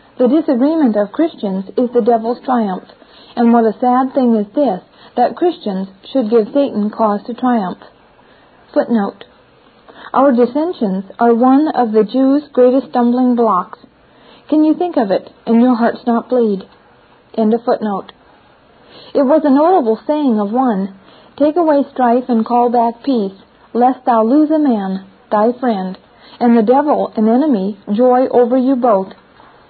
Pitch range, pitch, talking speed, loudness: 220-270 Hz, 245 Hz, 155 wpm, -14 LUFS